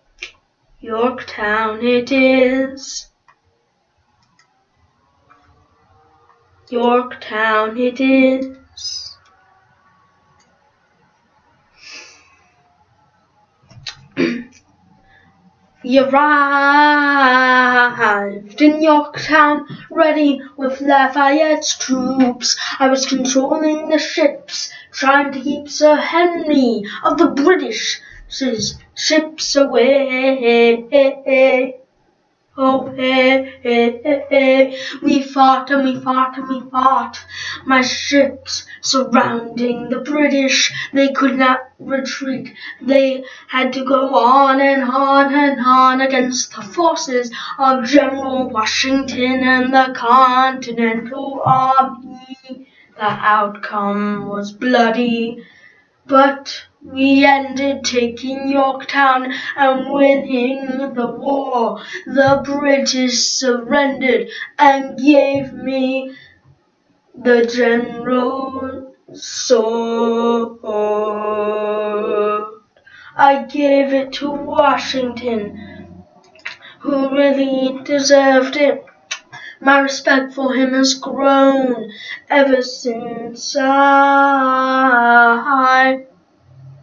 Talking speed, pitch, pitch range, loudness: 75 wpm, 265 Hz, 245-275 Hz, -15 LUFS